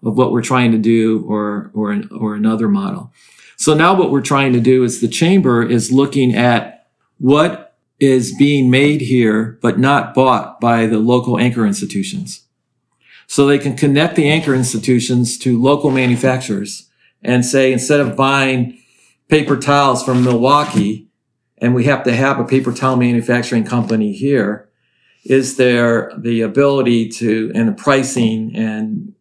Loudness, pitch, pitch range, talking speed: -14 LUFS, 125 Hz, 115-140 Hz, 155 wpm